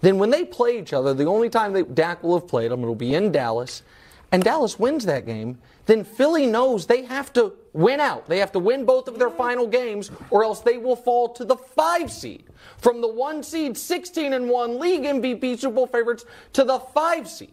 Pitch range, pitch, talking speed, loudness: 215-270 Hz, 245 Hz, 225 wpm, -22 LUFS